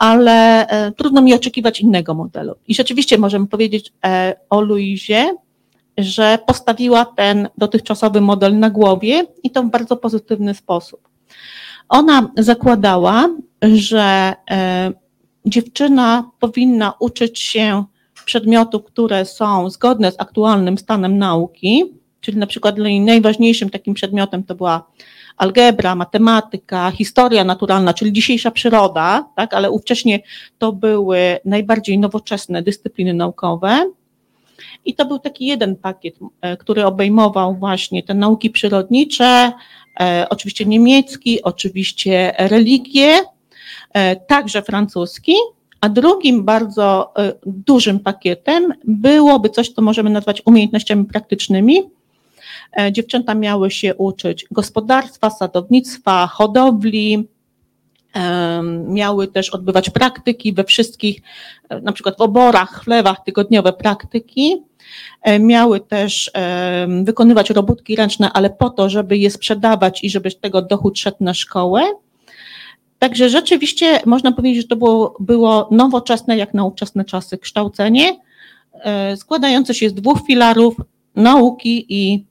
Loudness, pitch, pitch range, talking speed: -14 LUFS, 215 Hz, 195-235 Hz, 115 wpm